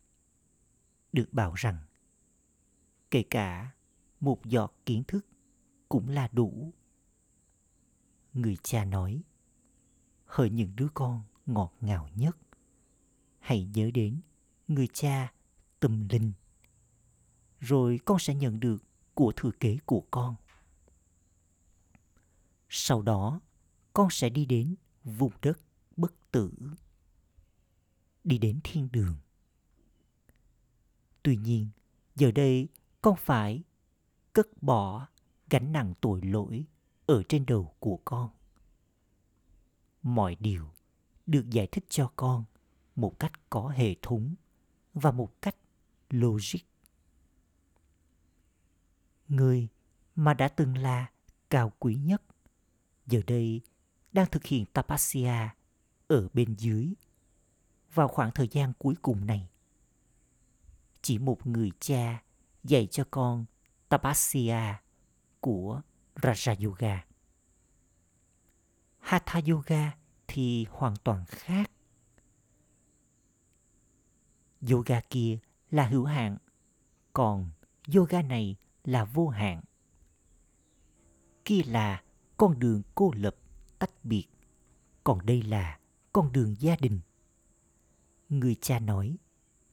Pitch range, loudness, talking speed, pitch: 90-135 Hz, -30 LUFS, 105 wpm, 115 Hz